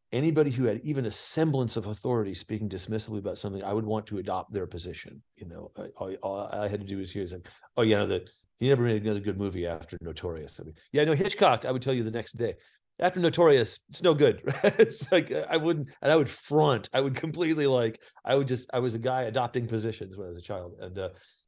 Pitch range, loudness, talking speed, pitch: 105-140 Hz, -28 LUFS, 250 wpm, 120 Hz